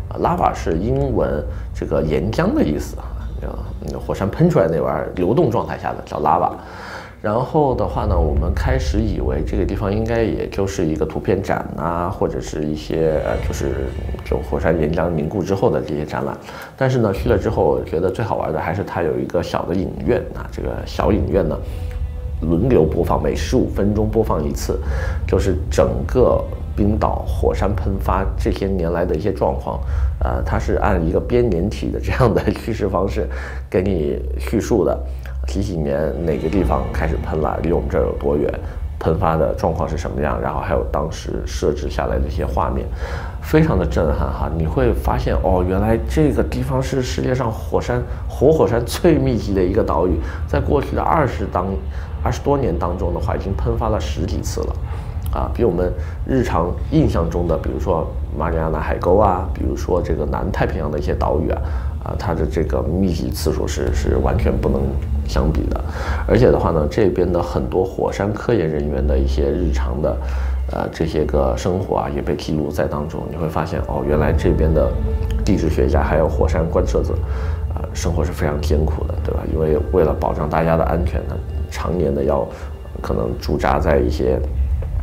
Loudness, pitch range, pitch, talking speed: -20 LUFS, 75-90 Hz, 80 Hz, 290 characters per minute